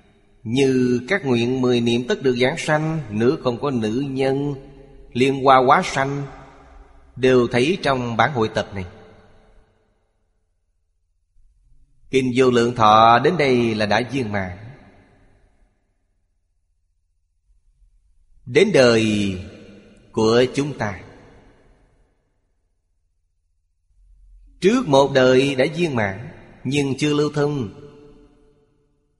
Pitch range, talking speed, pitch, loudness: 90-135 Hz, 105 wpm, 110 Hz, -18 LUFS